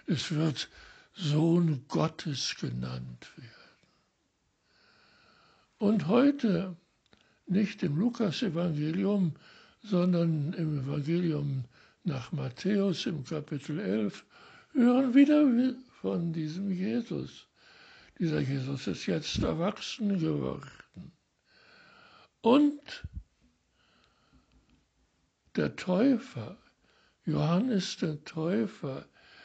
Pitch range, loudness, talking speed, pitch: 155-235 Hz, -30 LUFS, 75 wpm, 180 Hz